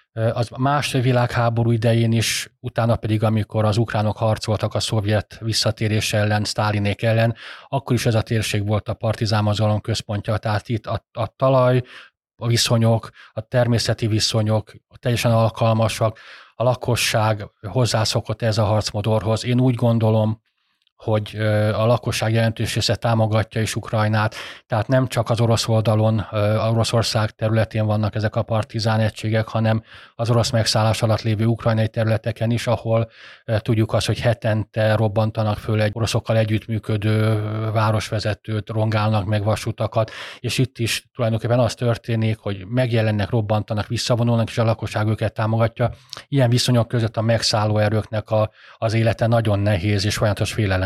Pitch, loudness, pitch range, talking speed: 110 Hz, -20 LUFS, 110-115 Hz, 140 wpm